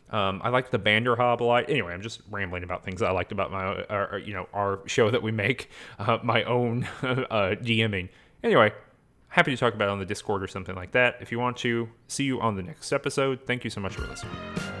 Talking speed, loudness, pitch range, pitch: 245 wpm, -27 LUFS, 100-125 Hz, 115 Hz